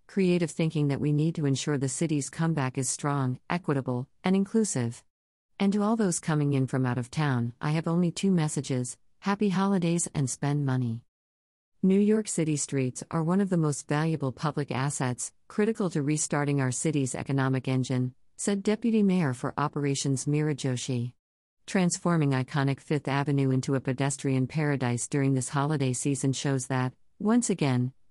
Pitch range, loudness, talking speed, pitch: 130-165 Hz, -28 LUFS, 165 wpm, 145 Hz